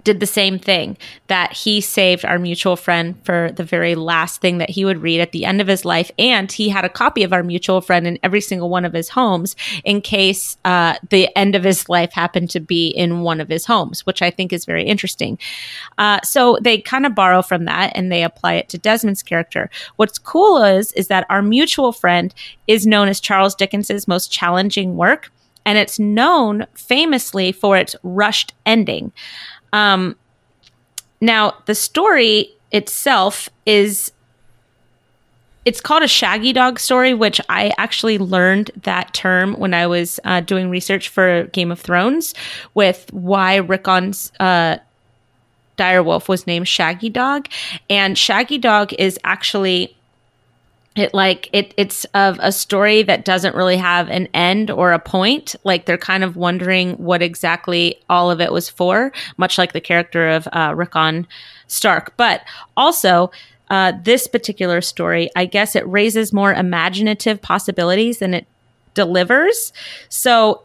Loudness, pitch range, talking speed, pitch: -15 LUFS, 175-210 Hz, 170 wpm, 190 Hz